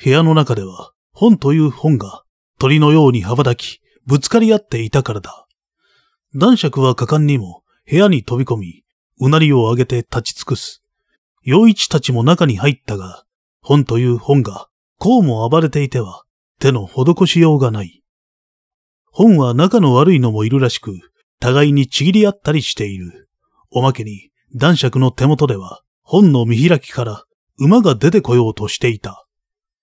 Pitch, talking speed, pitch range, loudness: 135 Hz, 305 characters per minute, 120-160 Hz, -14 LUFS